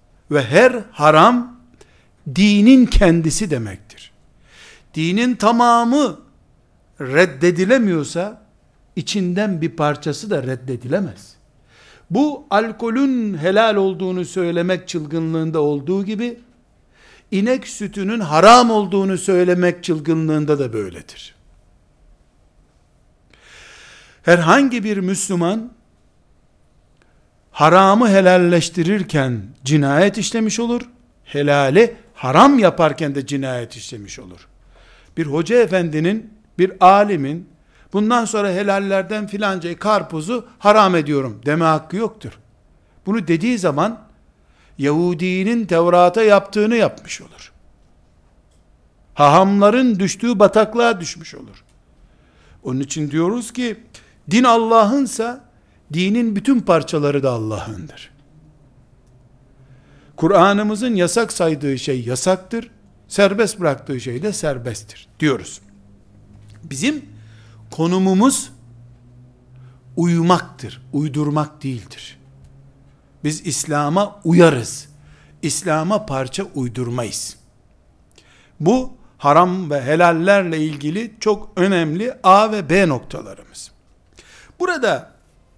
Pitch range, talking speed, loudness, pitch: 130-205 Hz, 85 wpm, -16 LUFS, 170 Hz